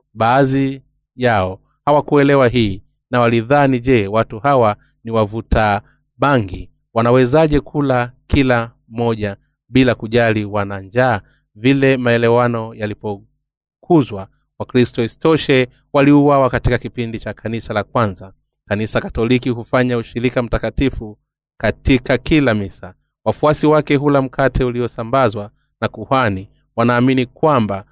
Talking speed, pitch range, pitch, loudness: 105 wpm, 110-135 Hz, 120 Hz, -16 LUFS